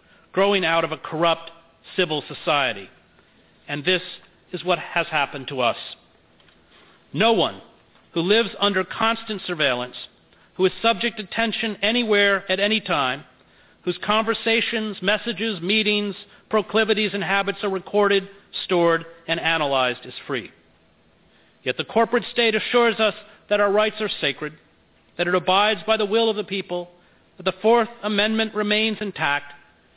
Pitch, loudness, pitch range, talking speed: 200 Hz, -22 LUFS, 165-215 Hz, 140 wpm